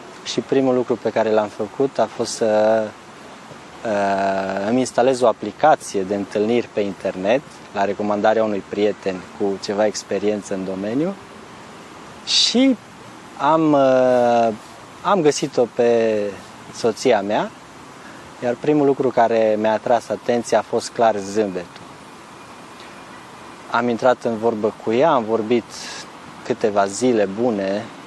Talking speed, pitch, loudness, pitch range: 120 wpm, 110 Hz, -19 LUFS, 100-120 Hz